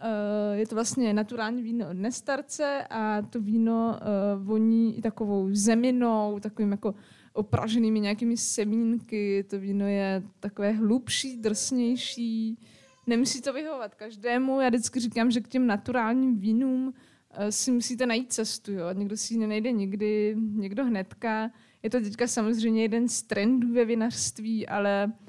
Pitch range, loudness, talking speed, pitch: 210-240 Hz, -27 LUFS, 140 wpm, 225 Hz